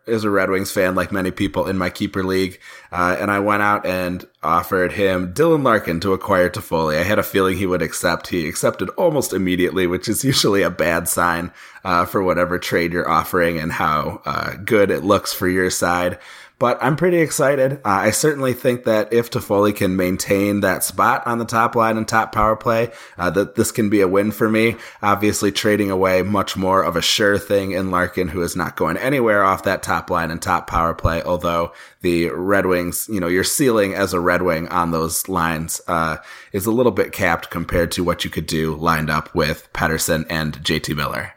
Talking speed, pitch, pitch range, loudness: 215 wpm, 95 Hz, 90-105 Hz, -19 LUFS